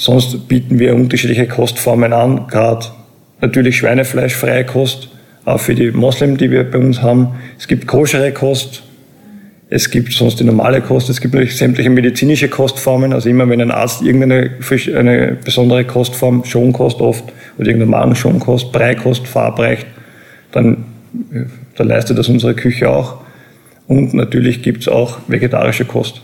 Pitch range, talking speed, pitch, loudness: 120-130 Hz, 150 wpm, 125 Hz, -12 LUFS